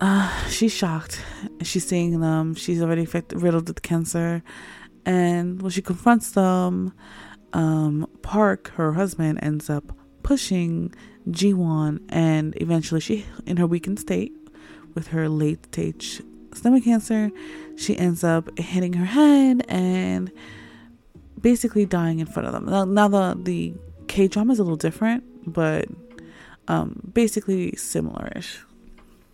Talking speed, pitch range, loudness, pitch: 135 wpm, 155-205 Hz, -23 LUFS, 175 Hz